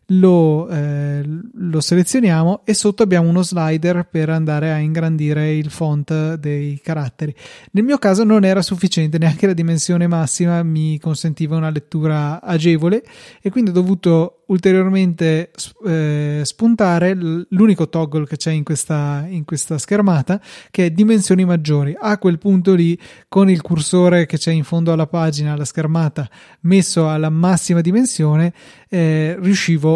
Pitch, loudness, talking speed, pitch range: 165 Hz, -16 LUFS, 145 wpm, 155-185 Hz